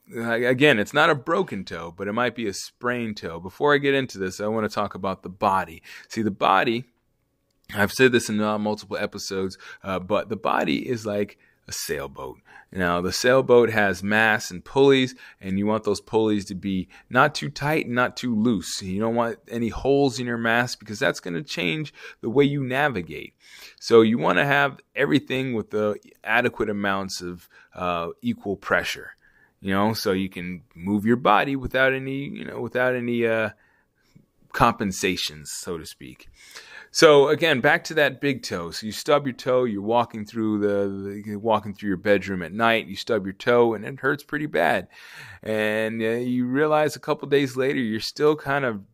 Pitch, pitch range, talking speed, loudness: 115 Hz, 100-130 Hz, 190 wpm, -23 LUFS